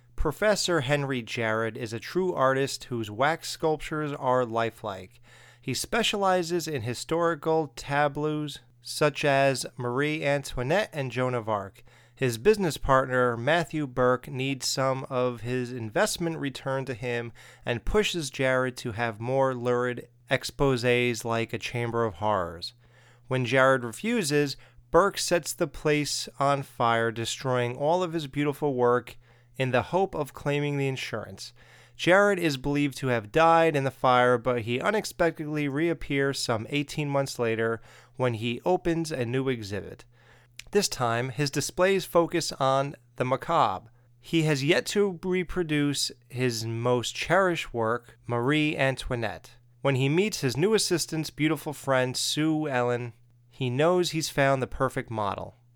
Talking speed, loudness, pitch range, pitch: 140 wpm, -27 LUFS, 120-150 Hz, 130 Hz